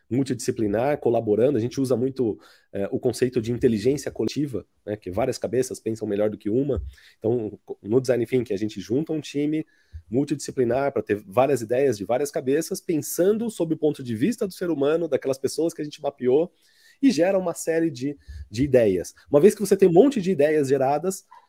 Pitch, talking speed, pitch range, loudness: 140 Hz, 195 wpm, 120-165 Hz, -24 LUFS